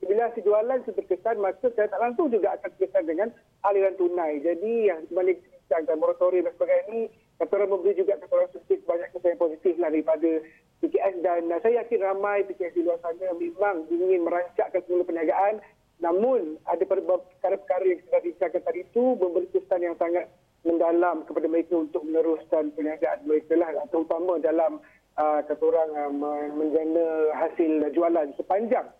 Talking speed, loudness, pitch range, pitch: 155 wpm, -26 LUFS, 165-200 Hz, 180 Hz